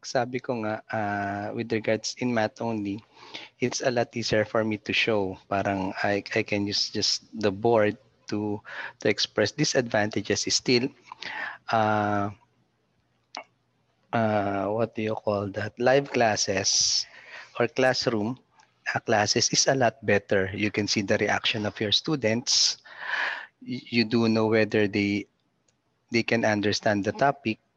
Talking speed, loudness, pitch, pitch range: 140 wpm, -25 LUFS, 110 Hz, 105-115 Hz